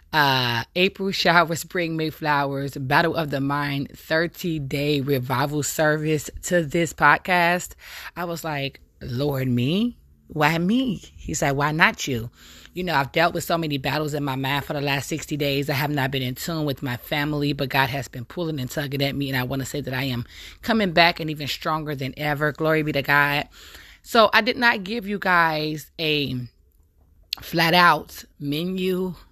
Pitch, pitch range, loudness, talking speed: 150 Hz, 140-170 Hz, -22 LUFS, 190 wpm